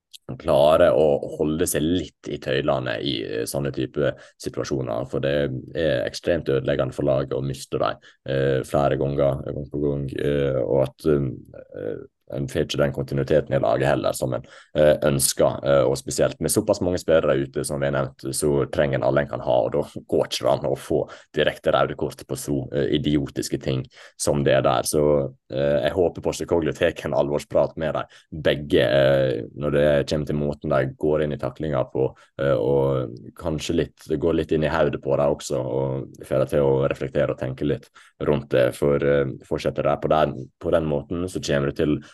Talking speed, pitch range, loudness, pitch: 175 wpm, 70-75 Hz, -23 LUFS, 70 Hz